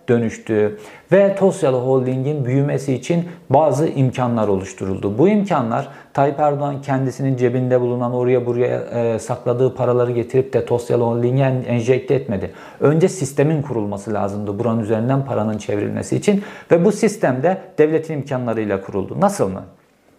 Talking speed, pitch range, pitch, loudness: 135 wpm, 115-145 Hz, 130 Hz, -19 LUFS